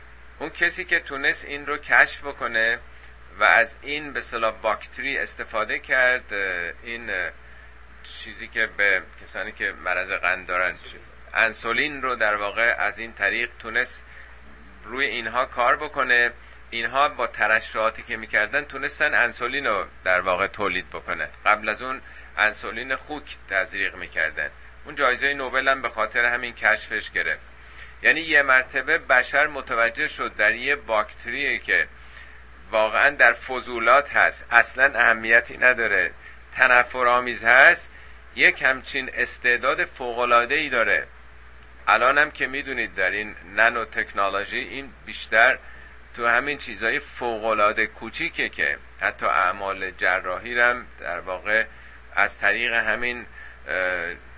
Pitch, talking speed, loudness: 110 Hz, 125 wpm, -22 LUFS